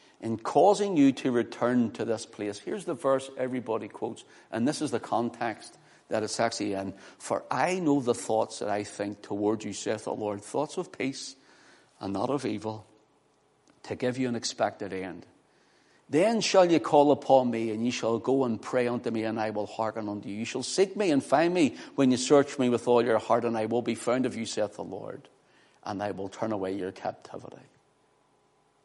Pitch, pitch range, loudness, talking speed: 120 Hz, 110-135 Hz, -28 LUFS, 210 wpm